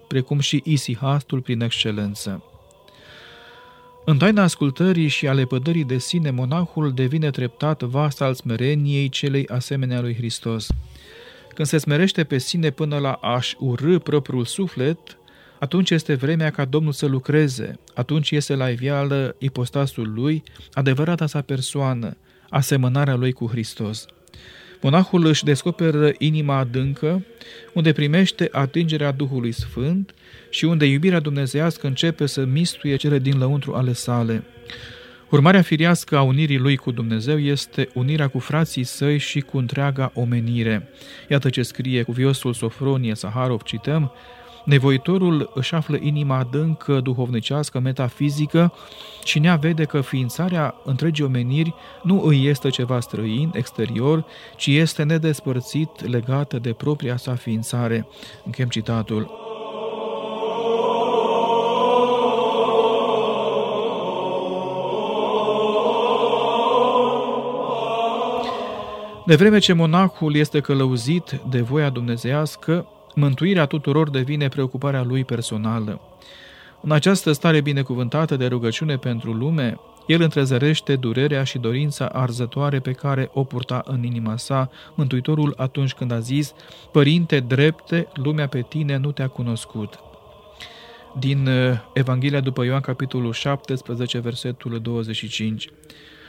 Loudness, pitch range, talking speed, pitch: -21 LUFS, 125-155 Hz, 115 wpm, 140 Hz